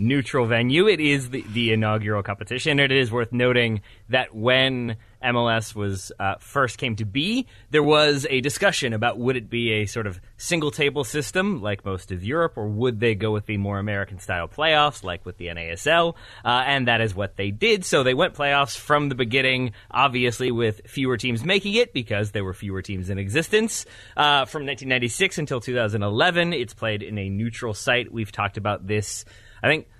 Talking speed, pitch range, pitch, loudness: 195 wpm, 105-140 Hz, 120 Hz, -22 LUFS